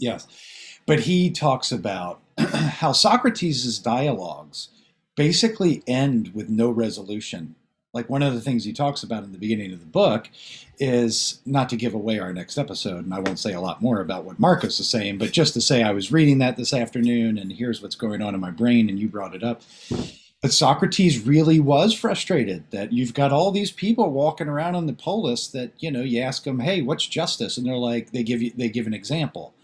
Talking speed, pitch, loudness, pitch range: 215 wpm, 120 Hz, -22 LUFS, 110-150 Hz